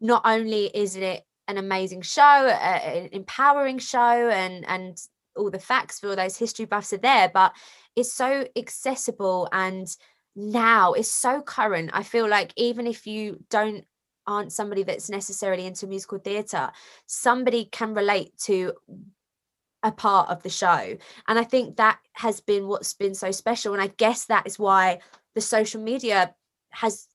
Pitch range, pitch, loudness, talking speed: 195-235 Hz, 210 Hz, -23 LUFS, 165 wpm